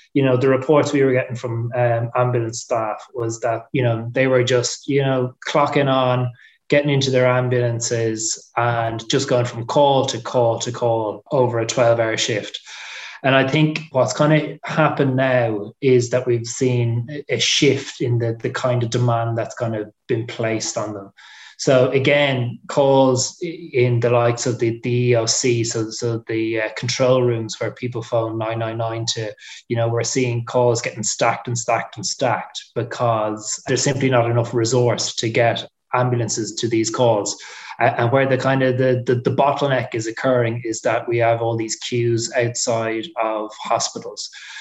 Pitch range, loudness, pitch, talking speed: 115-130 Hz, -19 LUFS, 120 Hz, 180 wpm